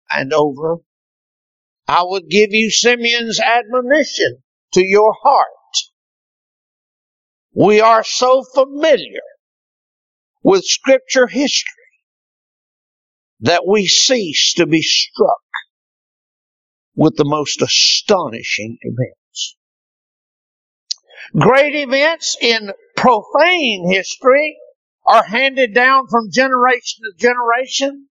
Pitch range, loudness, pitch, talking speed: 195-280 Hz, -13 LUFS, 245 Hz, 90 wpm